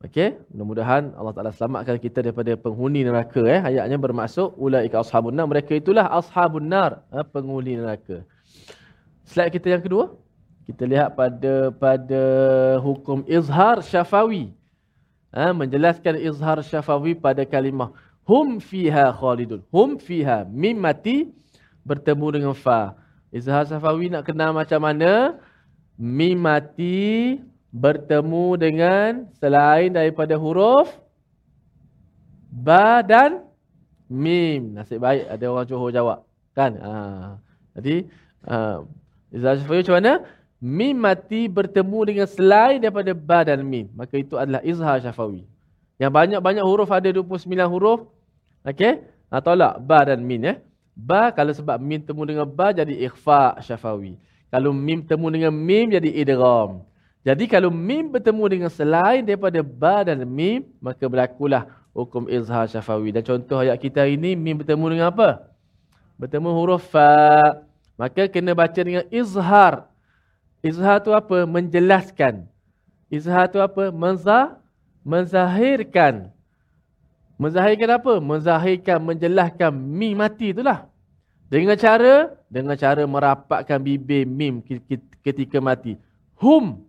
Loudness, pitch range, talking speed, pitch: -19 LUFS, 130-185 Hz, 125 wpm, 150 Hz